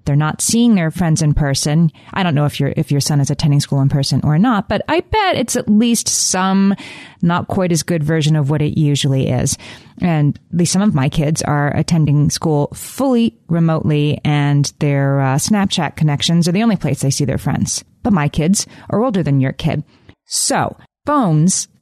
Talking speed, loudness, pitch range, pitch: 200 wpm, -16 LUFS, 145-190 Hz, 155 Hz